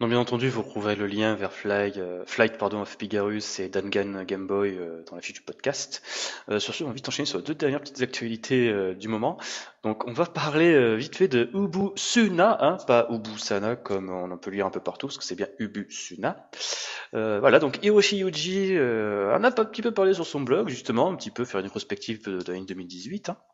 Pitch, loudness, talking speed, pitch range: 110 Hz, -26 LUFS, 235 wpm, 100-155 Hz